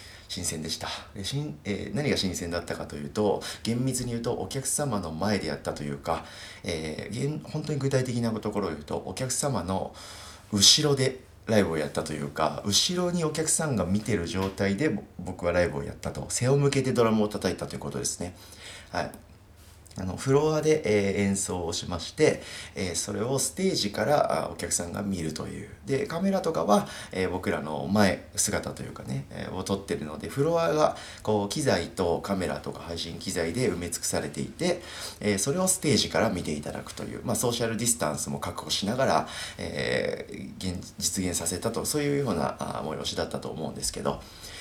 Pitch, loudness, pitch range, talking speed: 100 Hz, -28 LUFS, 85-115 Hz, 355 characters per minute